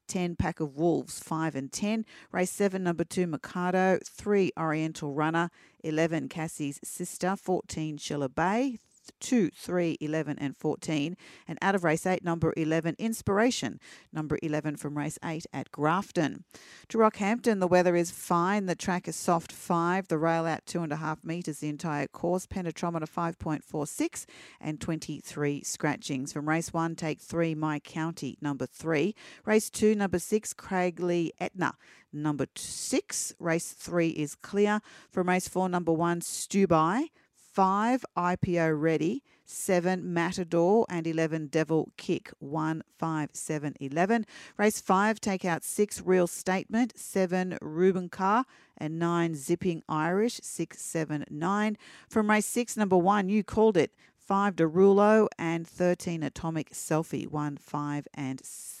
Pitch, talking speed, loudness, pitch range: 170 Hz, 145 wpm, -29 LUFS, 155-190 Hz